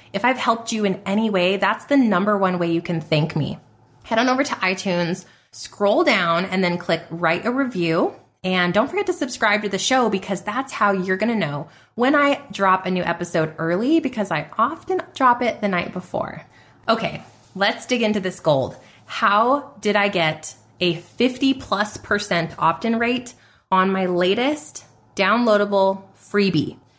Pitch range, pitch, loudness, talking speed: 175-230 Hz, 195 Hz, -20 LUFS, 180 wpm